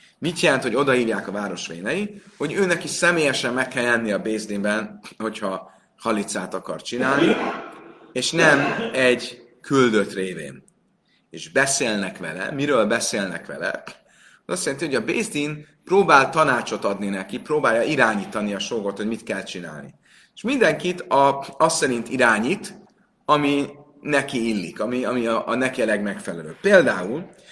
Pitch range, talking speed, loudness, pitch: 110-155 Hz, 145 wpm, -21 LUFS, 130 Hz